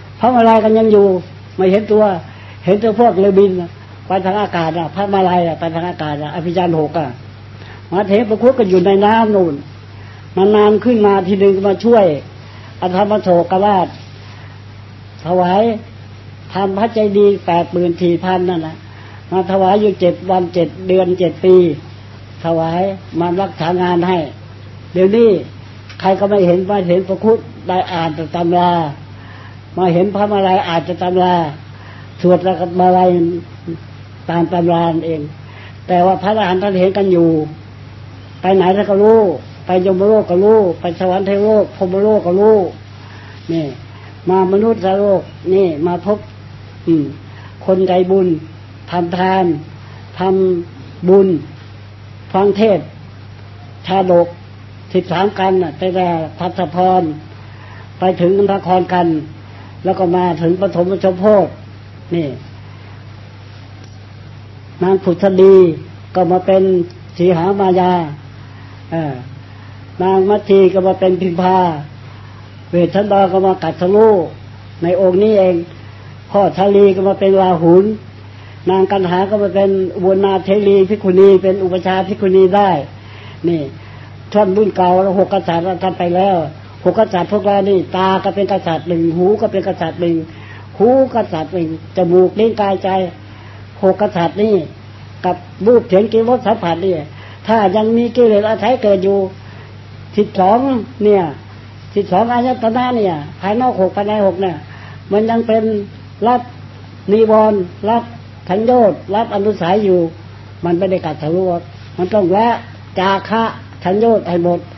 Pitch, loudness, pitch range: 180 Hz, -13 LUFS, 120-195 Hz